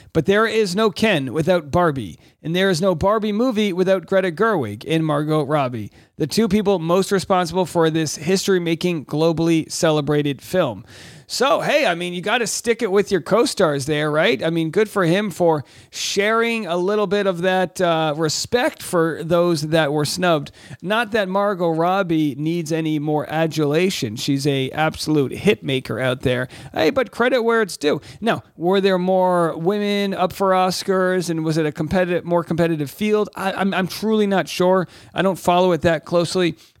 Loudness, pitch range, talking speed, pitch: -19 LUFS, 155-195 Hz, 185 wpm, 175 Hz